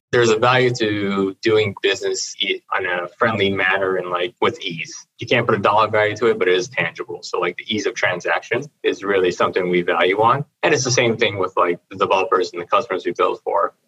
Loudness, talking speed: -19 LUFS, 230 wpm